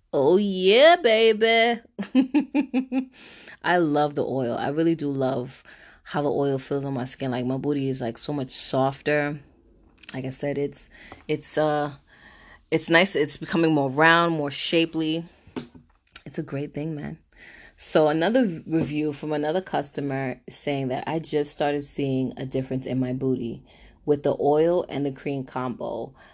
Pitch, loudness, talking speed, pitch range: 145 Hz, -24 LUFS, 155 wpm, 135-165 Hz